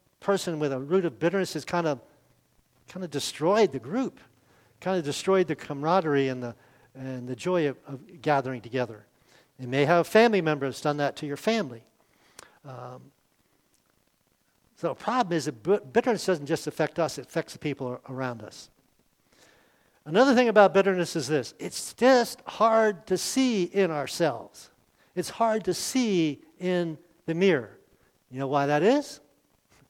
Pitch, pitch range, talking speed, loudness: 160 Hz, 135-190 Hz, 165 wpm, -26 LUFS